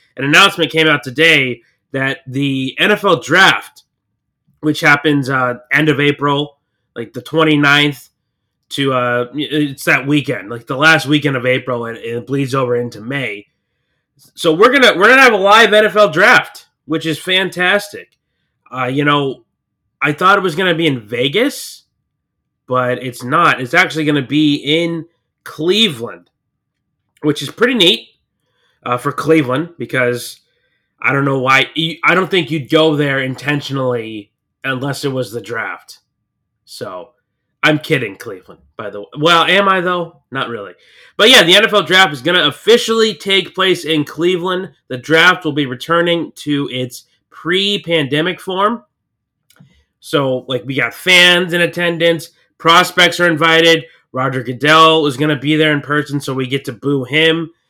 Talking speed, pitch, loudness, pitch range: 165 wpm, 150 Hz, -13 LUFS, 130-170 Hz